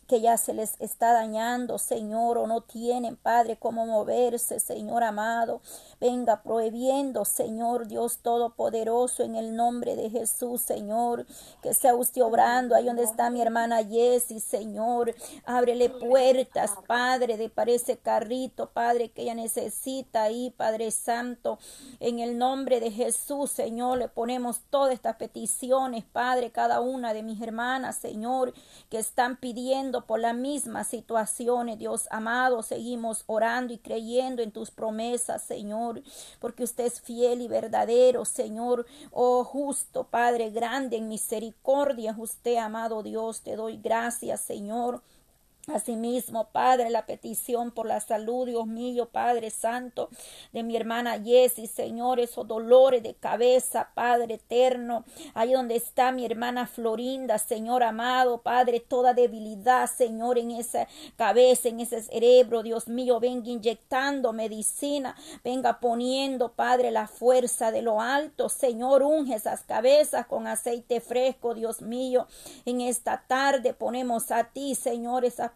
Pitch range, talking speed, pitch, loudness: 230-250 Hz, 140 wpm, 240 Hz, -27 LUFS